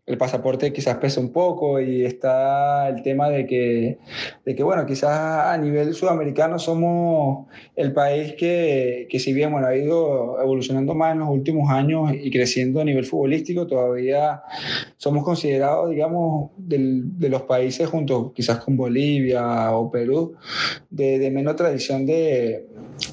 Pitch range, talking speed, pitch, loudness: 130-155 Hz, 155 wpm, 140 Hz, -21 LUFS